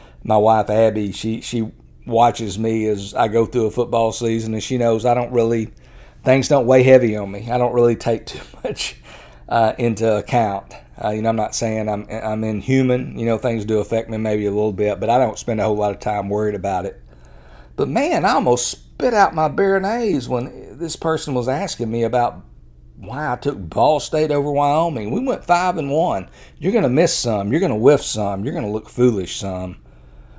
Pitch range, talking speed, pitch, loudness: 105-125 Hz, 210 wpm, 115 Hz, -19 LUFS